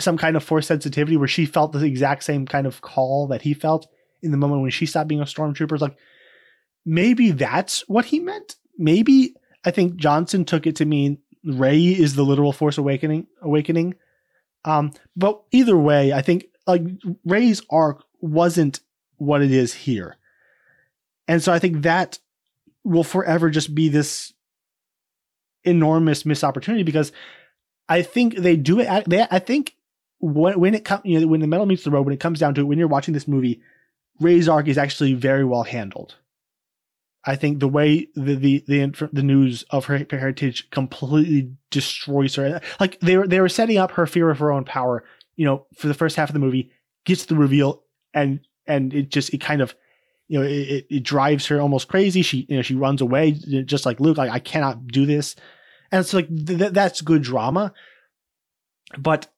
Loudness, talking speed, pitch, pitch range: -20 LUFS, 190 wpm, 155 Hz, 140-175 Hz